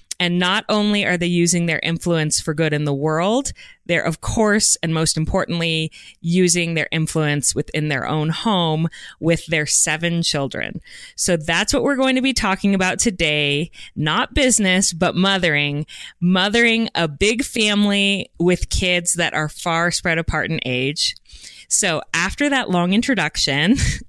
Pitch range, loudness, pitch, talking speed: 160-200 Hz, -18 LUFS, 170 Hz, 155 wpm